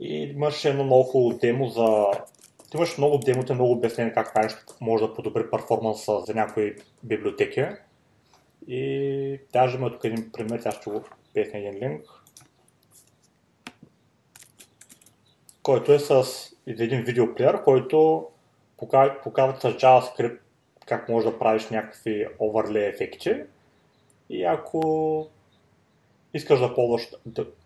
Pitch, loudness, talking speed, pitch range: 125 Hz, -24 LUFS, 115 wpm, 110-135 Hz